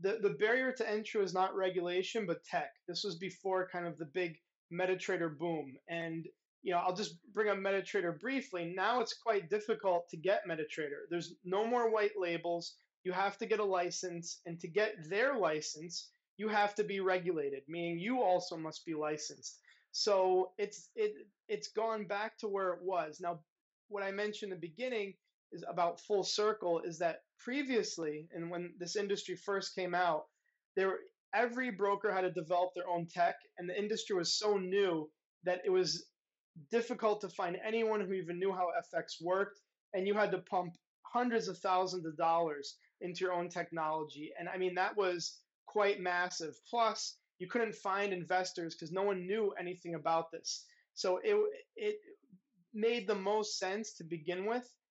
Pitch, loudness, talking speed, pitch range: 185 Hz, -36 LUFS, 180 wpm, 175-210 Hz